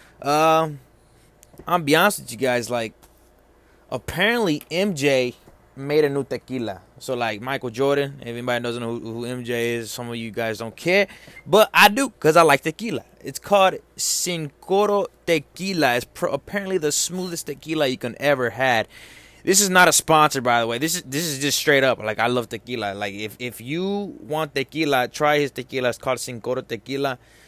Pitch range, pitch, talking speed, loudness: 120-160 Hz, 140 Hz, 190 wpm, -21 LUFS